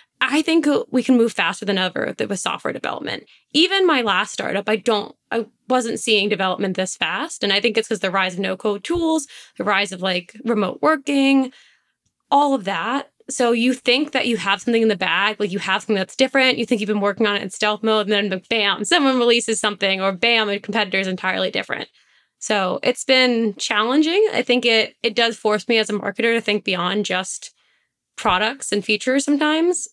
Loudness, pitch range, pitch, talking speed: -19 LUFS, 200-255 Hz, 225 Hz, 205 wpm